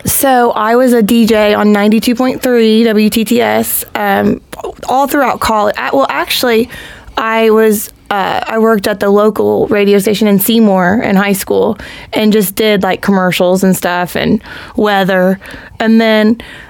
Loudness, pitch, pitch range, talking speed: -10 LUFS, 215 Hz, 205-230 Hz, 155 wpm